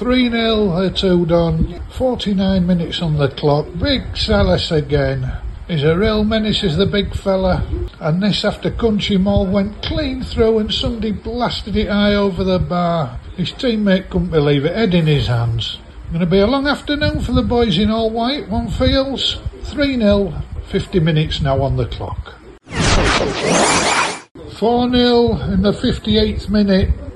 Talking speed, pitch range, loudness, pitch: 160 wpm, 160-220 Hz, -17 LUFS, 195 Hz